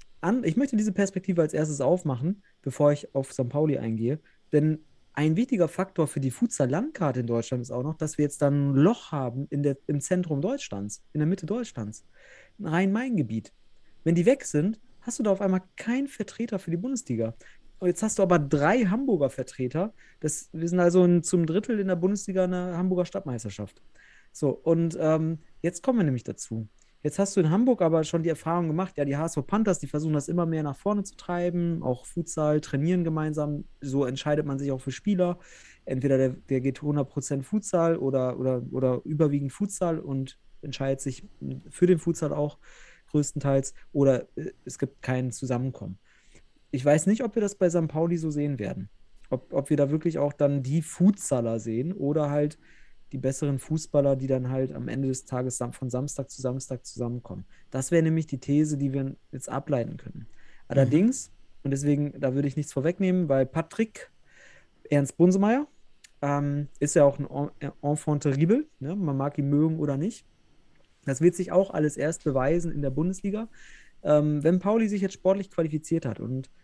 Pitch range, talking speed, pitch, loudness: 135-180 Hz, 185 wpm, 150 Hz, -27 LUFS